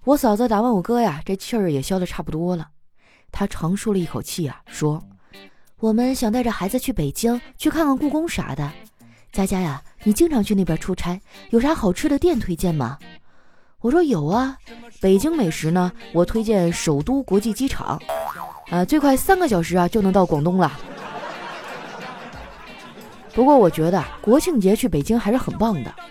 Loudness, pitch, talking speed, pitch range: -20 LUFS, 195 Hz, 255 characters per minute, 170-245 Hz